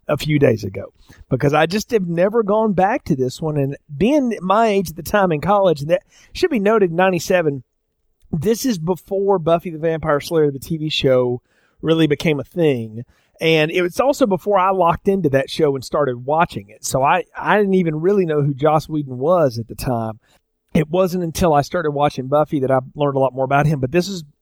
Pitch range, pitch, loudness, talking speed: 145-190 Hz, 160 Hz, -18 LUFS, 220 wpm